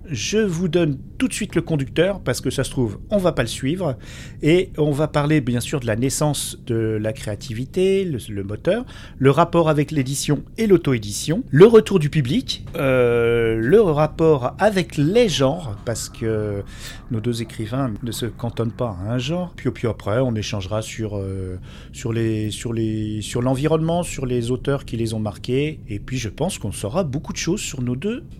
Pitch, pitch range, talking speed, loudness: 130 Hz, 115-155 Hz, 205 wpm, -21 LUFS